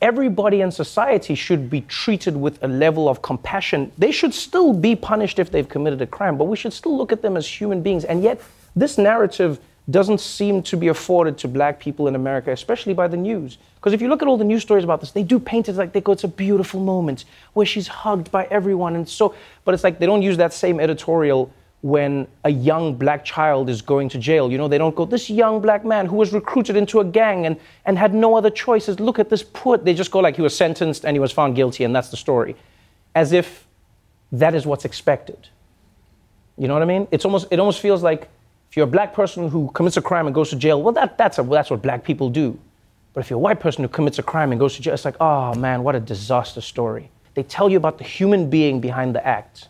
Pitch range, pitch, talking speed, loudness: 145-205 Hz, 170 Hz, 250 wpm, -19 LUFS